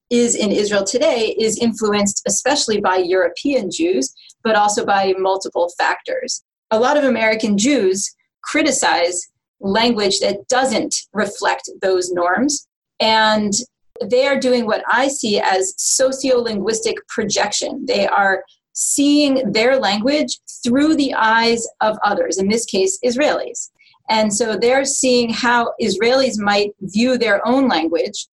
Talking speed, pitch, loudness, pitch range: 130 wpm, 230 Hz, -17 LUFS, 200-265 Hz